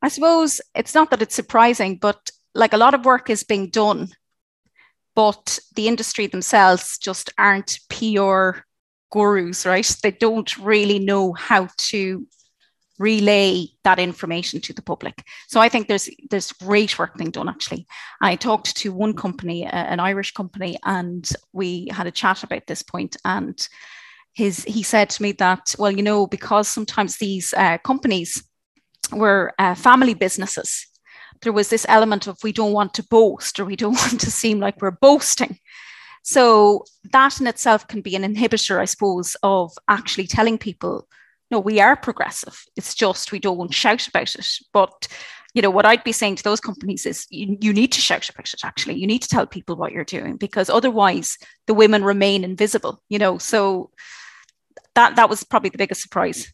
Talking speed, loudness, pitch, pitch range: 185 wpm, -19 LUFS, 205 Hz, 190-225 Hz